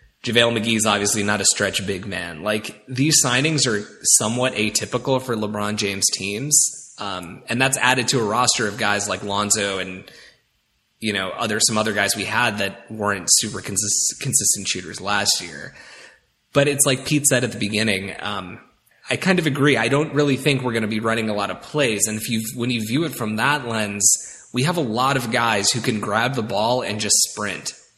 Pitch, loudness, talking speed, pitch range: 110 Hz, -19 LUFS, 210 wpm, 100-125 Hz